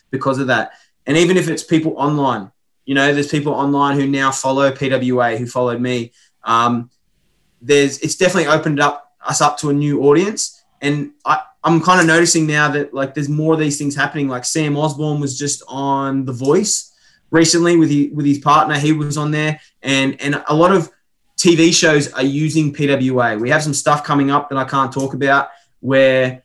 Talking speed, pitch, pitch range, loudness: 200 wpm, 145 Hz, 135-155 Hz, -16 LUFS